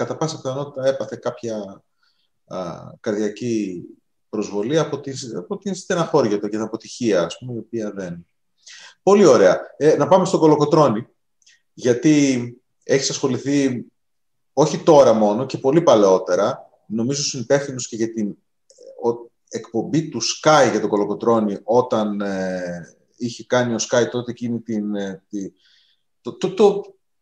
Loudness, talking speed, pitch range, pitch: -19 LUFS, 140 wpm, 105-140 Hz, 120 Hz